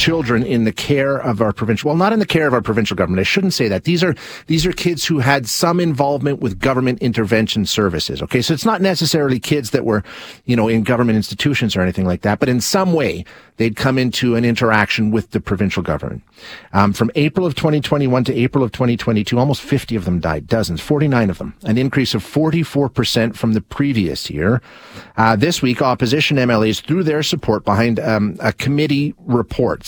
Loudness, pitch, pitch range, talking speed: -17 LUFS, 125 Hz, 110-145 Hz, 205 wpm